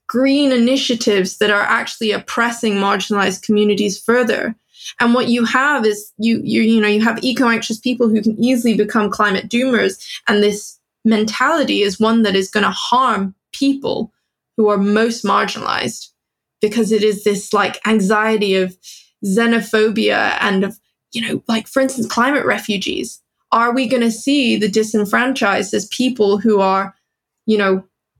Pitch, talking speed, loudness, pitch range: 220 Hz, 155 wpm, -16 LUFS, 205-235 Hz